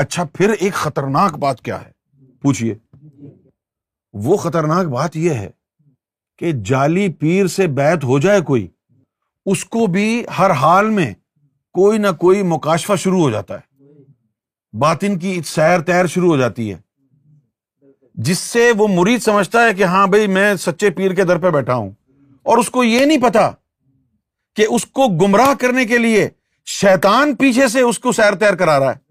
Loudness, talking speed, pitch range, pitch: -15 LUFS, 170 wpm, 135-200 Hz, 175 Hz